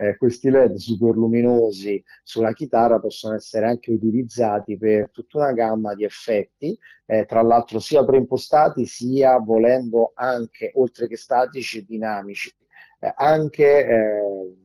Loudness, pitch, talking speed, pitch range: -20 LUFS, 115 Hz, 130 wpm, 110-130 Hz